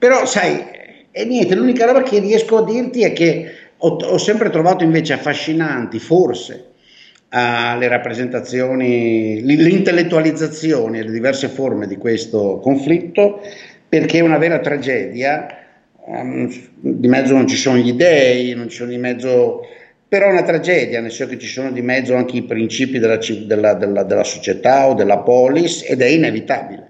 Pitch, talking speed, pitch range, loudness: 135 Hz, 150 wpm, 120-170 Hz, -15 LUFS